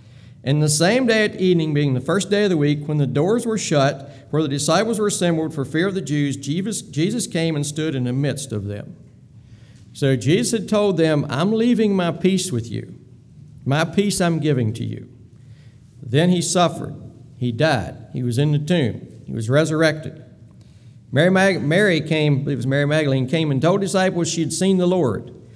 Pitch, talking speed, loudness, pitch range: 150 Hz, 195 wpm, -20 LUFS, 130-175 Hz